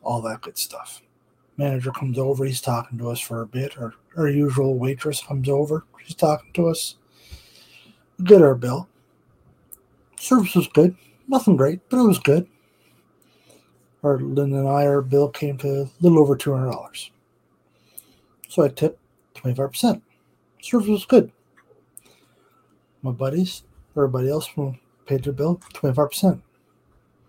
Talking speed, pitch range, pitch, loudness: 145 wpm, 130-160 Hz, 140 Hz, -21 LUFS